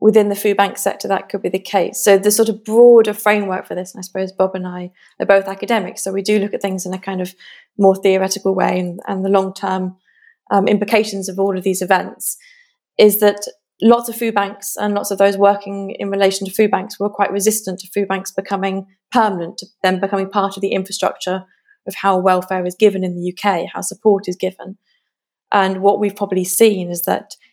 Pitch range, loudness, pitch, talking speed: 190-210 Hz, -17 LUFS, 195 Hz, 220 wpm